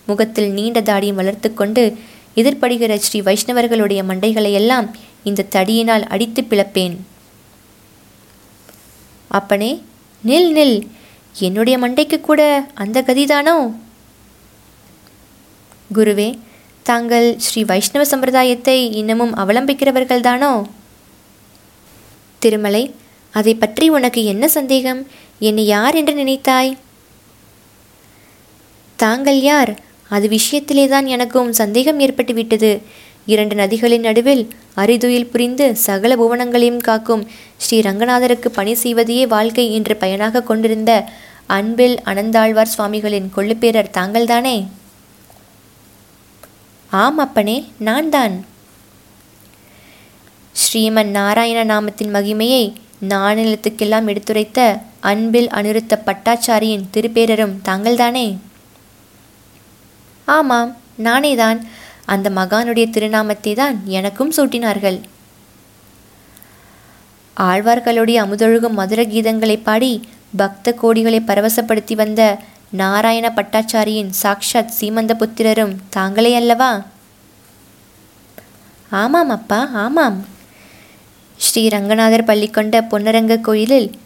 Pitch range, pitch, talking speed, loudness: 200-240 Hz, 220 Hz, 80 wpm, -15 LUFS